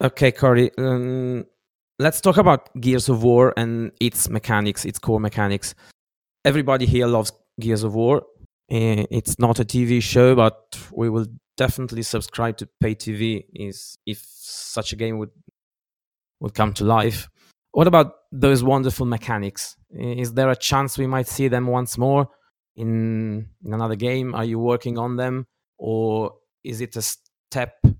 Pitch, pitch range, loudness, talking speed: 120 Hz, 110-130 Hz, -21 LUFS, 150 wpm